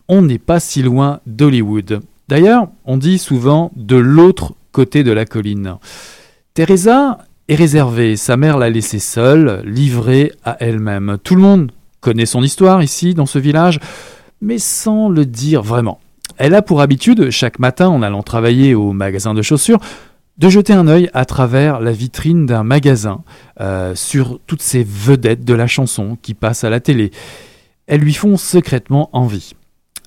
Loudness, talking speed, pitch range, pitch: -12 LUFS, 165 wpm, 115-165 Hz, 135 Hz